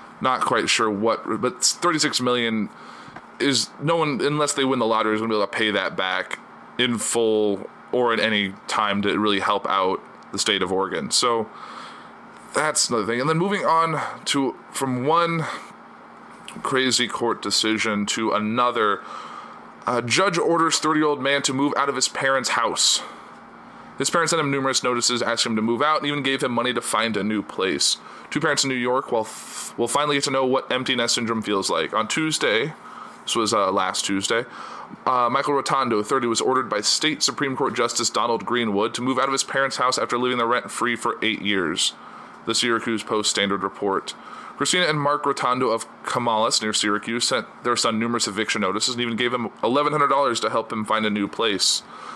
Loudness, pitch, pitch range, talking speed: -22 LUFS, 125 Hz, 110-140 Hz, 195 wpm